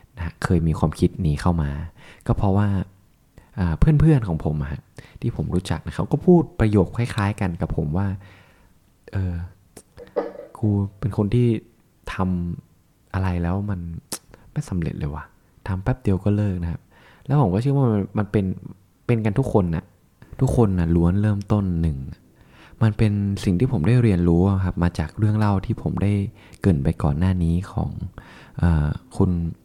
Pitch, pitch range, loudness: 95 Hz, 85-110 Hz, -22 LUFS